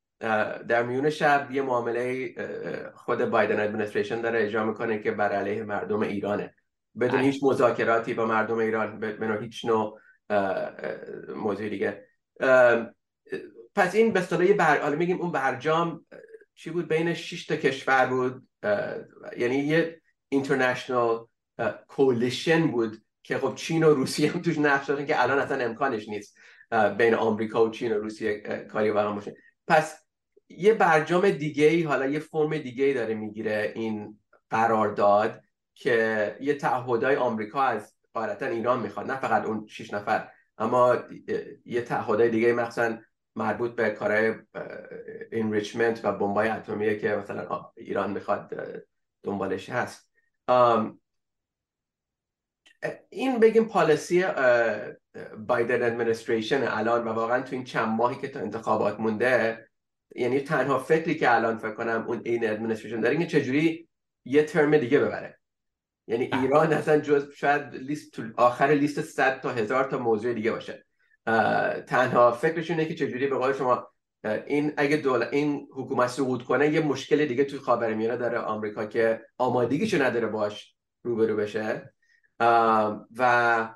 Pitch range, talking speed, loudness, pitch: 115-155 Hz, 140 wpm, -26 LUFS, 130 Hz